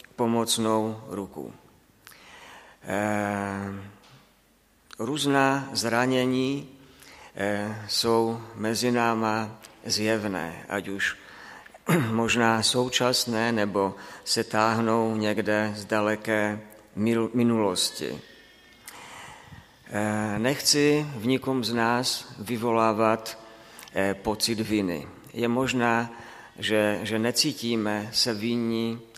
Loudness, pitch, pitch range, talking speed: -26 LUFS, 115 Hz, 105-120 Hz, 70 wpm